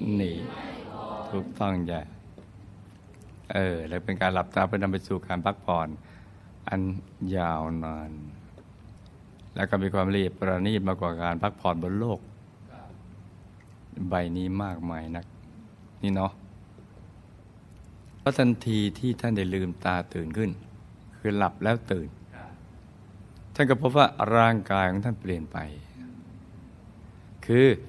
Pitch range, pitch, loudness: 90-105 Hz, 95 Hz, -28 LUFS